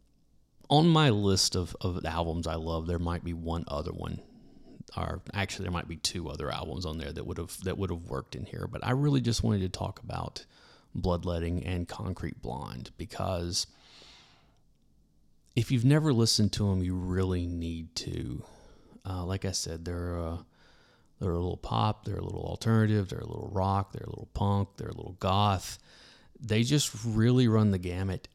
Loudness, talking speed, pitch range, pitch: -30 LUFS, 185 wpm, 85-110 Hz, 95 Hz